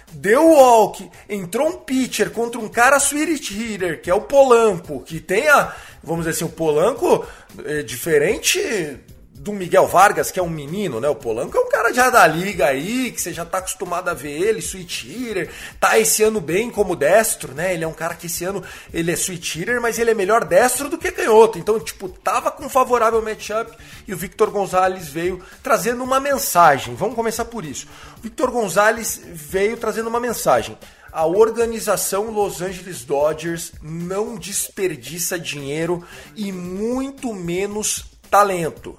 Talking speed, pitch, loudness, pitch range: 180 wpm, 205 Hz, -19 LUFS, 175-235 Hz